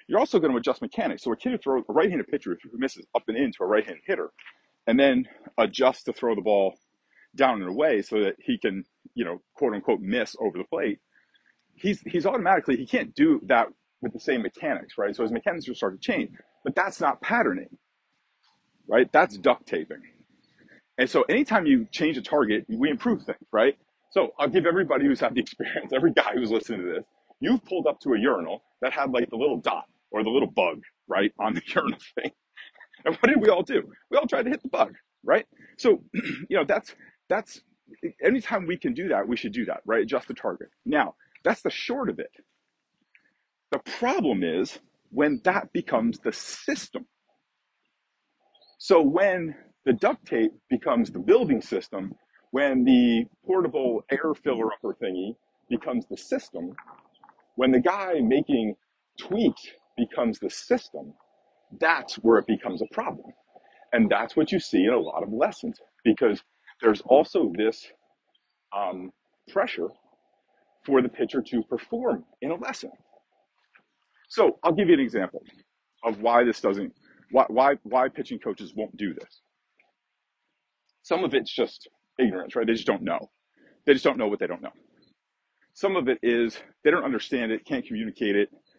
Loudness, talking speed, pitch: -25 LUFS, 180 wpm, 225 Hz